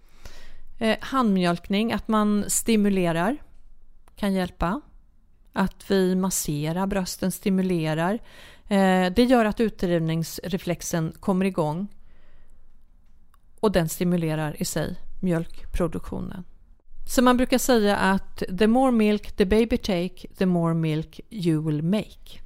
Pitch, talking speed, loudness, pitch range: 190 Hz, 105 wpm, -24 LUFS, 170-210 Hz